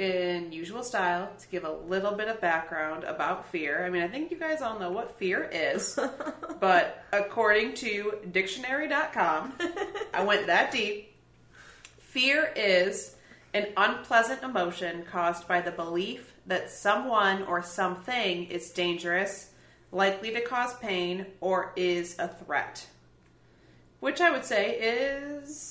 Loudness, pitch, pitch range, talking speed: -29 LUFS, 195 Hz, 180-245 Hz, 140 wpm